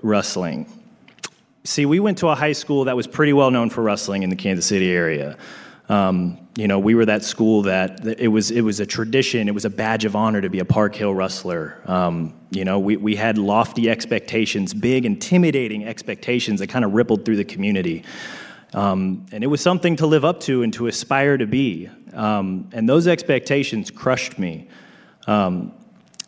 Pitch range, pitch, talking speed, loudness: 100-140 Hz, 110 Hz, 190 wpm, -20 LUFS